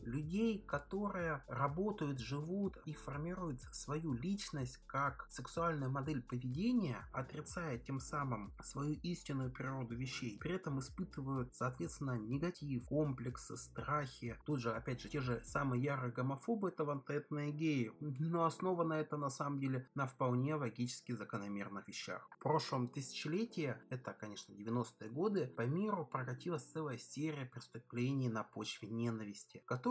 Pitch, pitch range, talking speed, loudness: 140 Hz, 125-155 Hz, 130 wpm, -41 LUFS